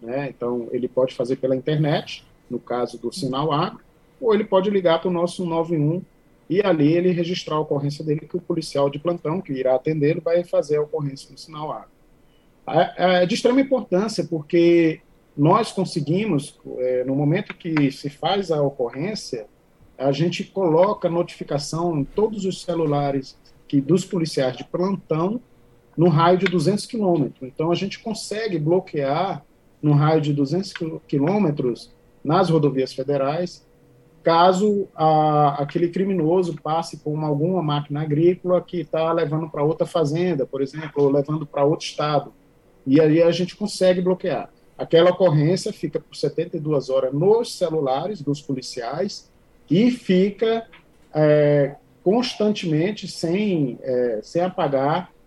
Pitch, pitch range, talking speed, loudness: 160 Hz, 145-180 Hz, 145 wpm, -21 LUFS